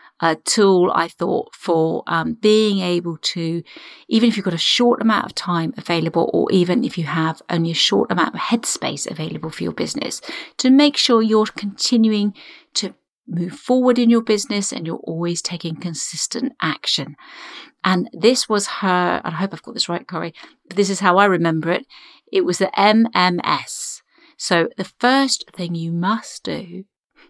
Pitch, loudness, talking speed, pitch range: 200 Hz, -19 LUFS, 180 wpm, 175-240 Hz